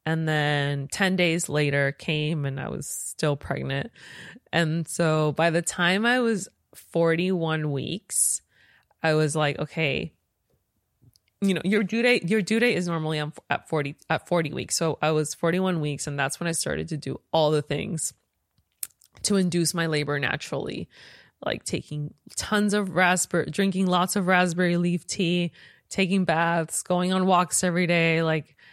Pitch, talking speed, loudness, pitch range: 165 Hz, 165 wpm, -25 LUFS, 150-185 Hz